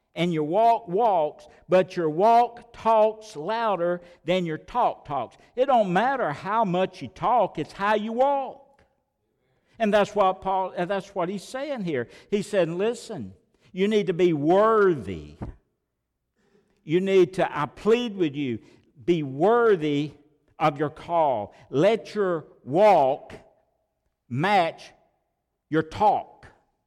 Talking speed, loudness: 130 wpm, -24 LUFS